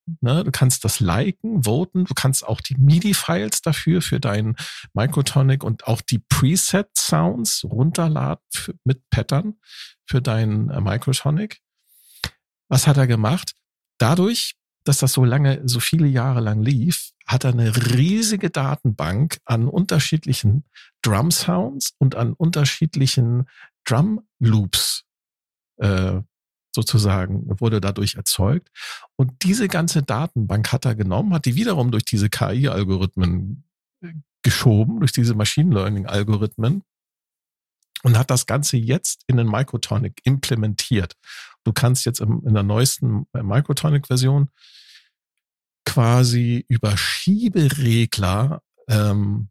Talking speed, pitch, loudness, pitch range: 115 wpm, 130 Hz, -20 LUFS, 110-150 Hz